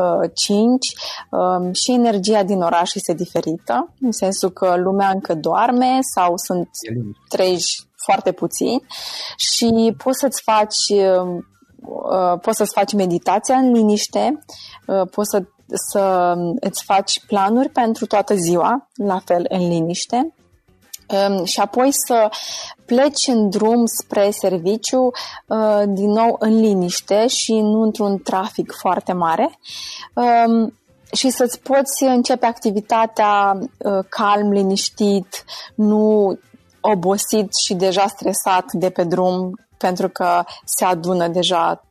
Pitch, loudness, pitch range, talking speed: 205 Hz, -18 LUFS, 185-230 Hz, 115 wpm